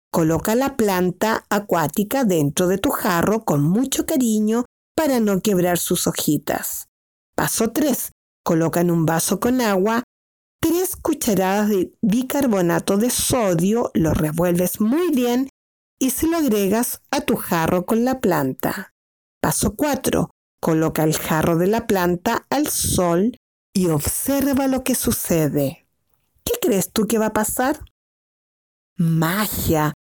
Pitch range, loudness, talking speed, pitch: 175-250 Hz, -20 LUFS, 135 wpm, 210 Hz